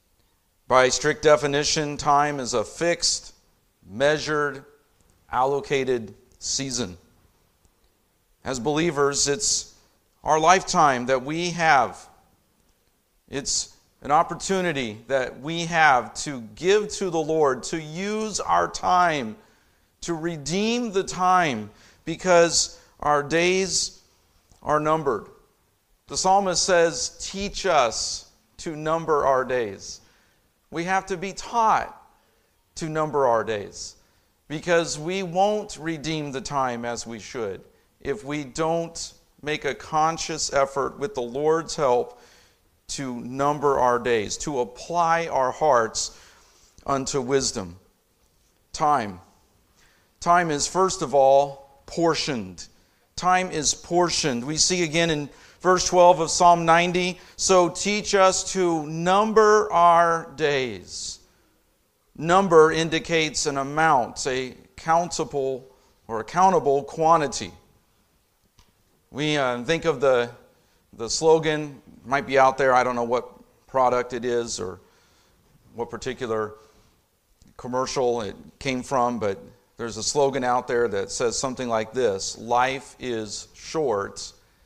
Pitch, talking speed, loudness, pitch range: 145 Hz, 115 wpm, -23 LUFS, 120-170 Hz